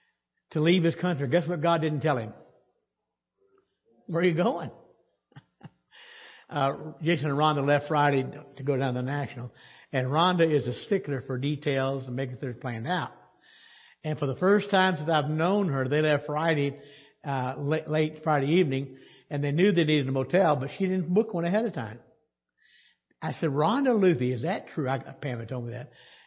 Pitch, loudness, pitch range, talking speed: 150 Hz, -27 LUFS, 135-175 Hz, 190 wpm